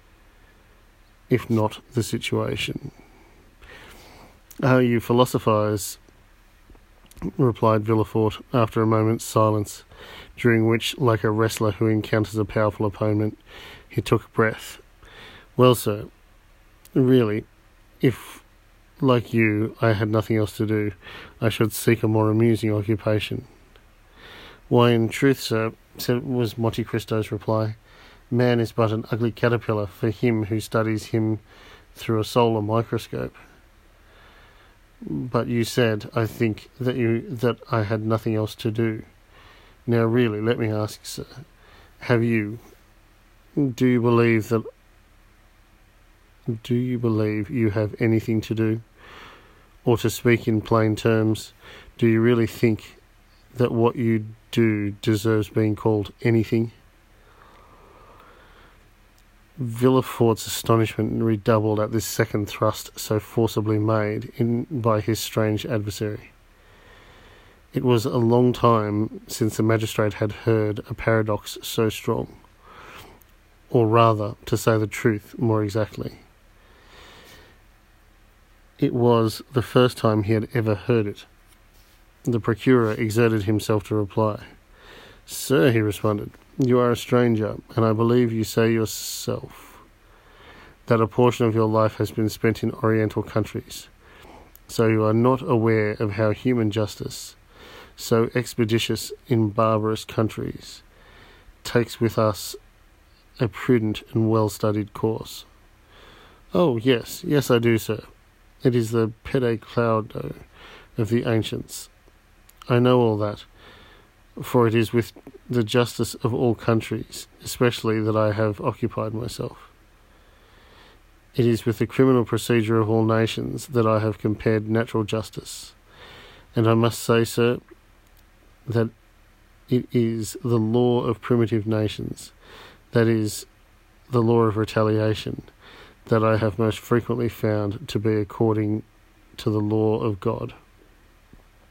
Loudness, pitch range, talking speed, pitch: -23 LUFS, 105-115 Hz, 130 wpm, 110 Hz